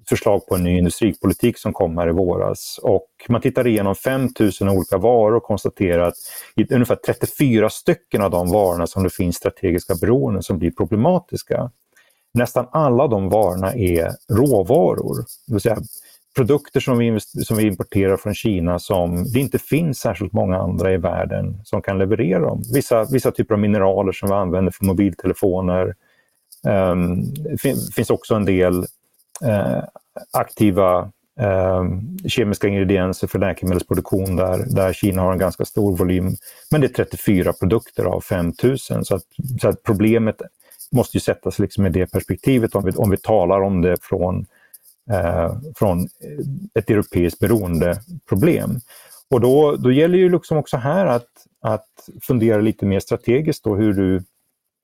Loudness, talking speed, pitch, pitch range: -19 LUFS, 160 wpm, 100 Hz, 95-120 Hz